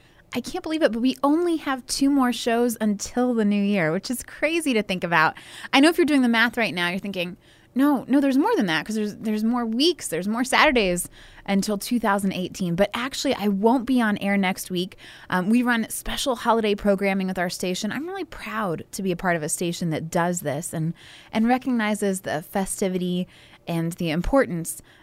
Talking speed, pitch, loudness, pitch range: 210 wpm, 210 Hz, -23 LUFS, 180-245 Hz